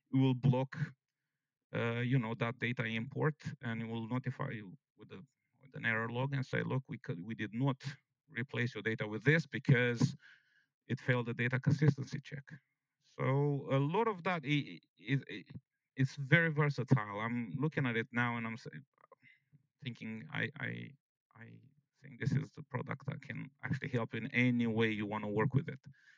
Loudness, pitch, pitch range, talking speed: -36 LUFS, 135 Hz, 115-145 Hz, 180 wpm